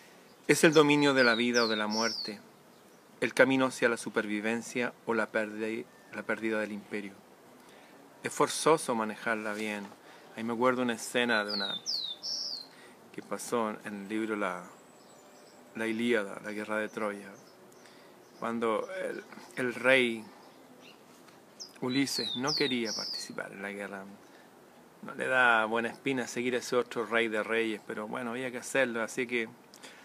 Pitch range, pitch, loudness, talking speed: 105-125 Hz, 115 Hz, -30 LUFS, 150 wpm